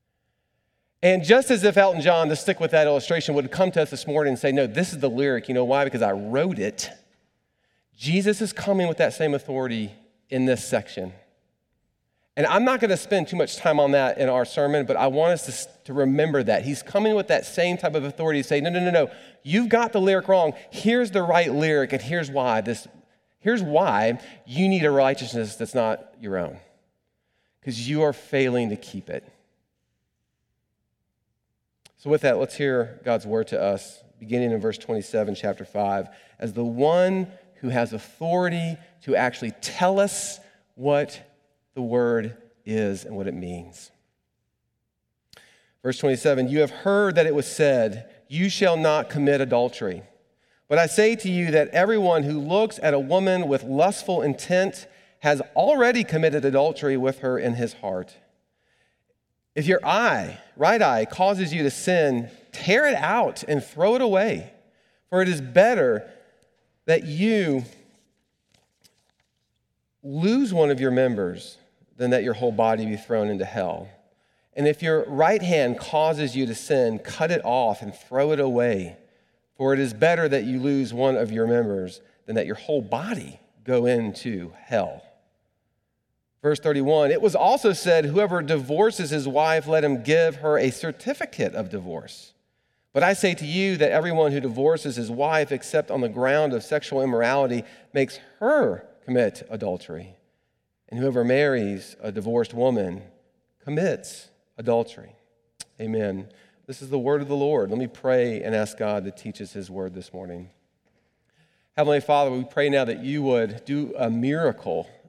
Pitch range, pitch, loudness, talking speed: 120-165 Hz, 140 Hz, -23 LUFS, 170 wpm